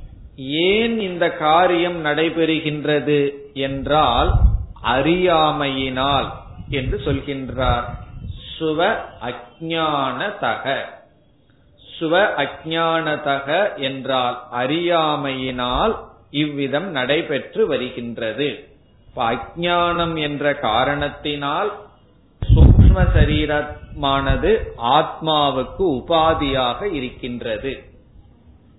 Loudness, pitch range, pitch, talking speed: -19 LUFS, 130-160 Hz, 145 Hz, 50 wpm